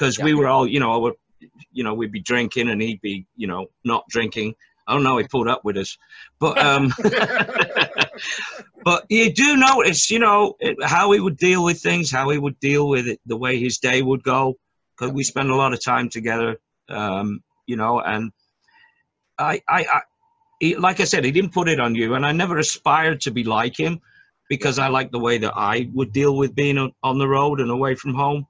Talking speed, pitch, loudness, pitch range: 220 wpm, 135 Hz, -19 LUFS, 120-165 Hz